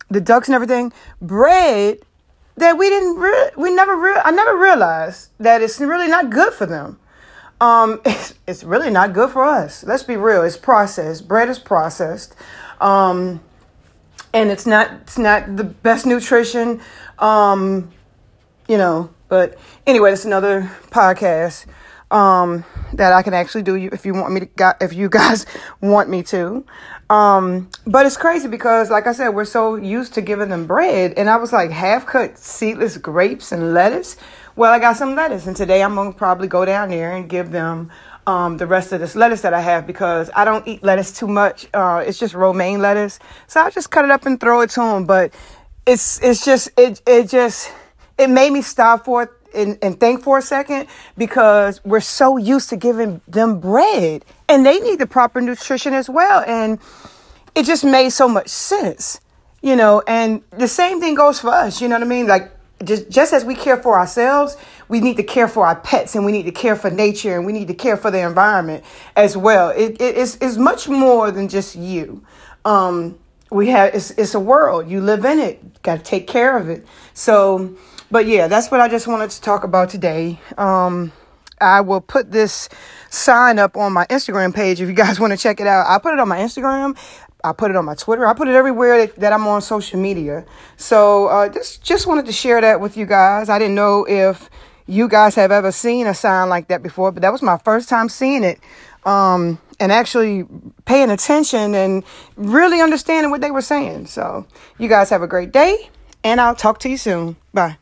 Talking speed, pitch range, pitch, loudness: 205 wpm, 190-250 Hz, 215 Hz, -15 LUFS